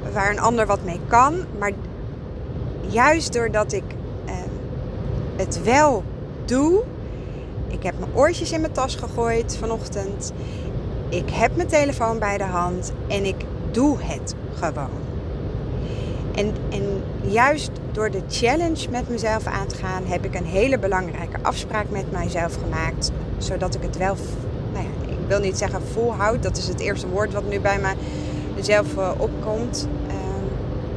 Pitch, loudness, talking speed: 205 Hz, -23 LUFS, 150 wpm